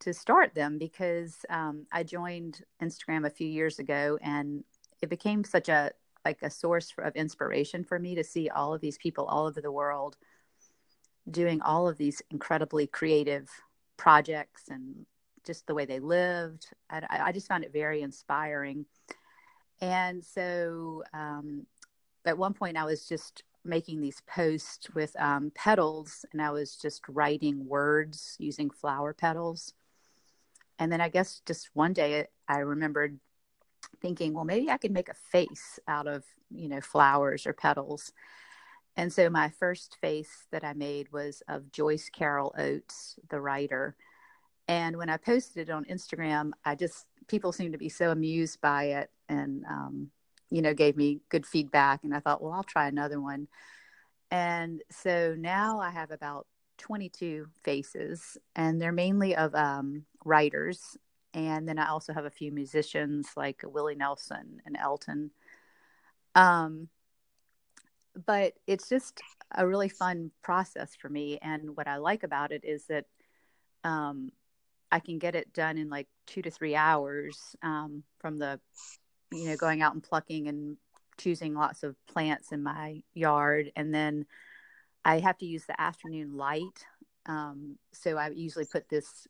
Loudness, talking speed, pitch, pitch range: -31 LUFS, 160 wpm, 155 Hz, 145-170 Hz